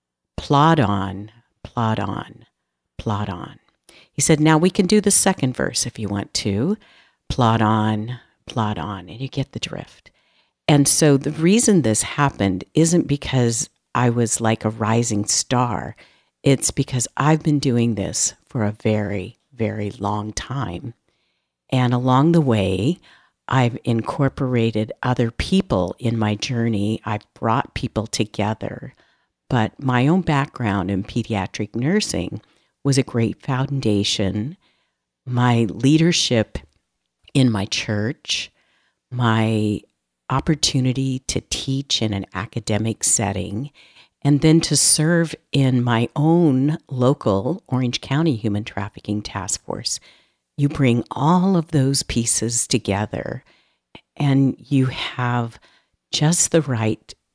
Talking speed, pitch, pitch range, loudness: 125 wpm, 120 Hz, 105-140 Hz, -20 LUFS